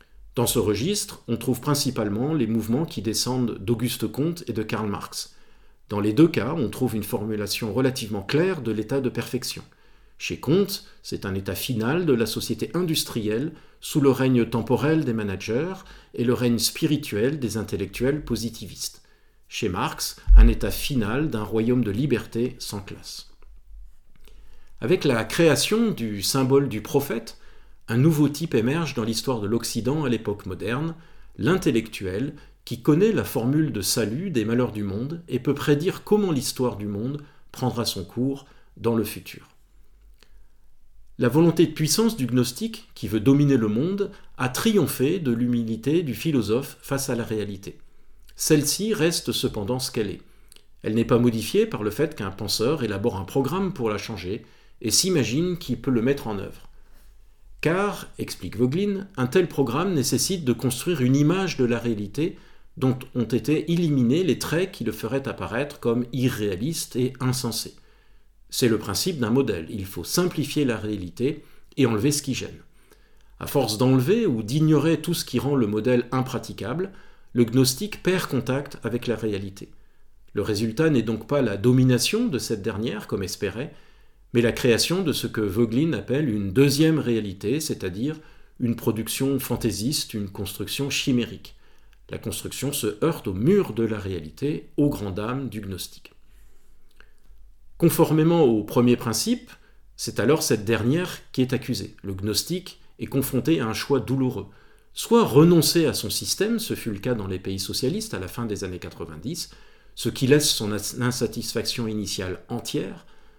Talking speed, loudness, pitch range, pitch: 160 wpm, -24 LUFS, 110-145 Hz, 125 Hz